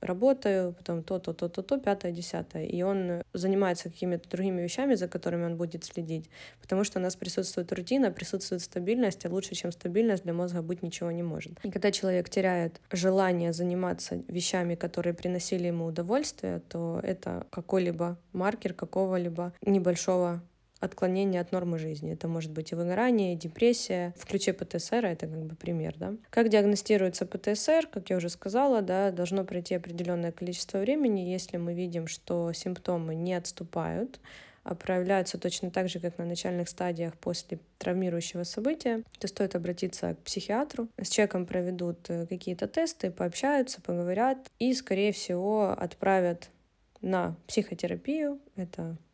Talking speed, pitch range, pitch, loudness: 145 wpm, 175-200 Hz, 180 Hz, -31 LUFS